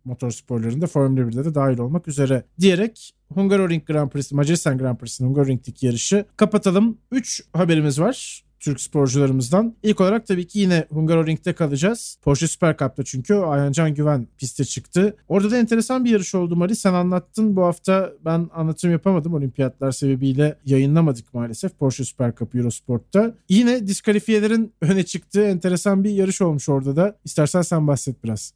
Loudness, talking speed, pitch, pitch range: -20 LUFS, 160 wpm, 165 Hz, 135-195 Hz